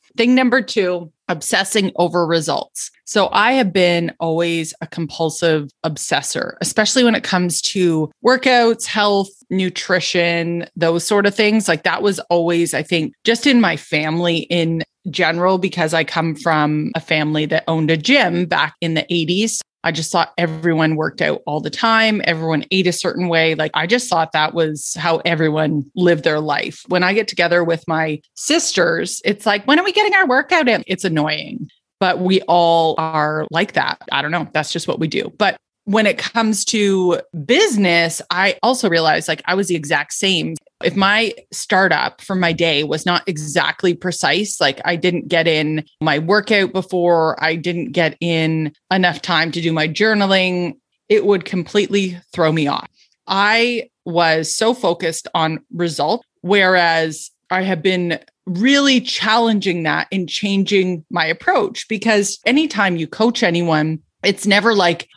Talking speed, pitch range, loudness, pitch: 170 wpm, 165-205 Hz, -17 LUFS, 175 Hz